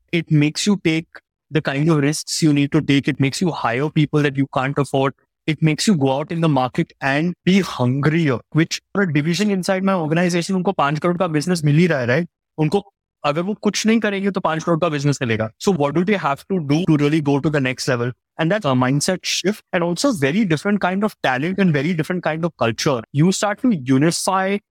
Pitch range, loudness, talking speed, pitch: 145-185 Hz, -19 LUFS, 190 wpm, 160 Hz